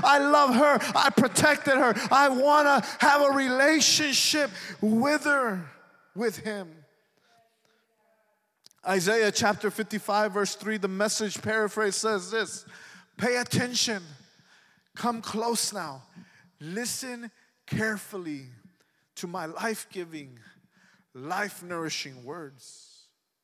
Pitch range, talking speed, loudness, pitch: 190-245 Hz, 100 wpm, -25 LUFS, 215 Hz